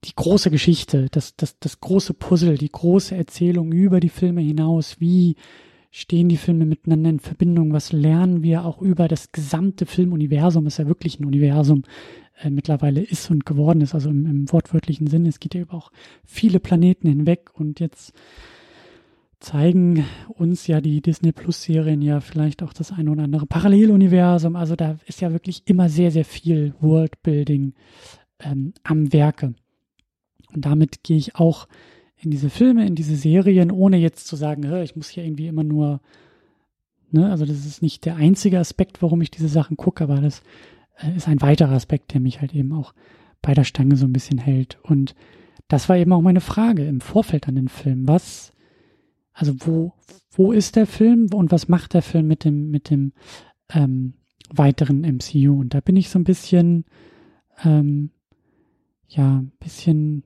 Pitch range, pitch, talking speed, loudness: 145-175 Hz, 160 Hz, 175 wpm, -19 LUFS